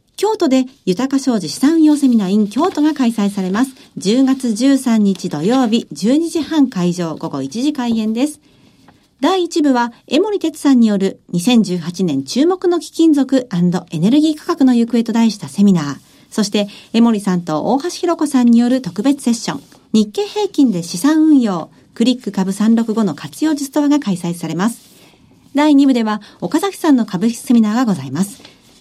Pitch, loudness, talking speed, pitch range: 240 Hz, -15 LUFS, 310 characters per minute, 200-290 Hz